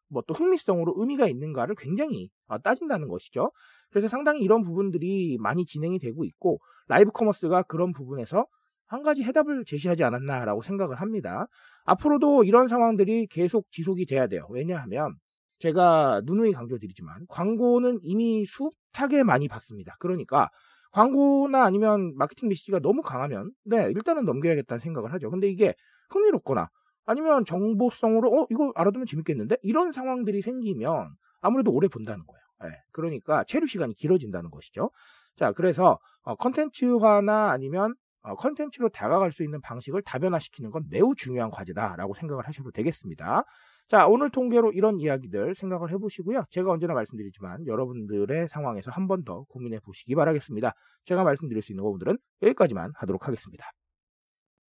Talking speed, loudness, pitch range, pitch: 405 characters per minute, -25 LUFS, 145-230 Hz, 190 Hz